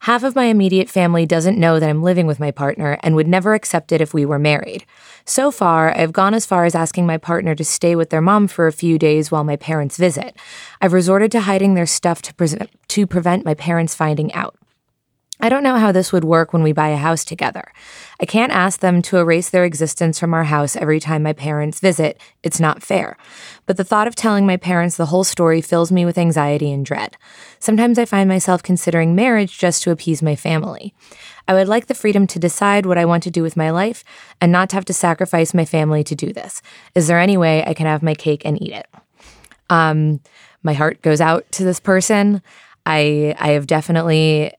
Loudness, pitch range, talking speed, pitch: -16 LUFS, 155-190 Hz, 225 wpm, 170 Hz